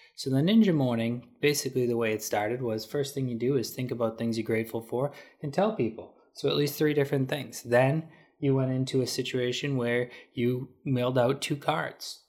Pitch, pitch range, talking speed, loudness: 130 Hz, 120-145 Hz, 205 wpm, -28 LUFS